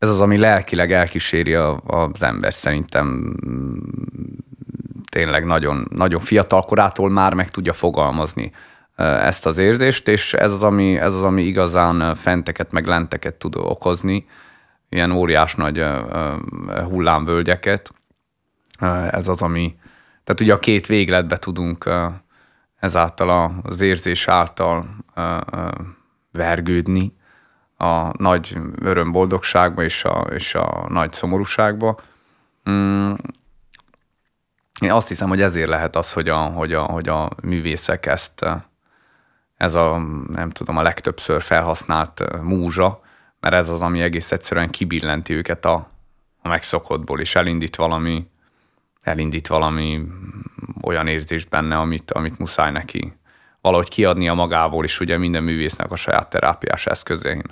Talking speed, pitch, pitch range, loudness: 120 wpm, 85 Hz, 80-95 Hz, -19 LUFS